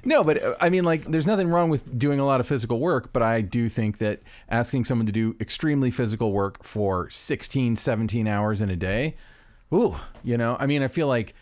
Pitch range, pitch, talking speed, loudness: 110-140 Hz, 120 Hz, 220 wpm, -24 LUFS